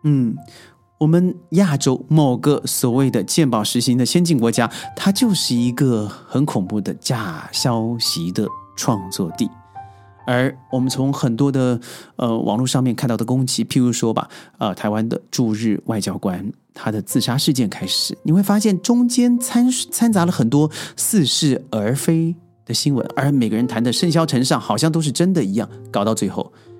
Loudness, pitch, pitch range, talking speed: -19 LUFS, 130 Hz, 115-160 Hz, 255 characters per minute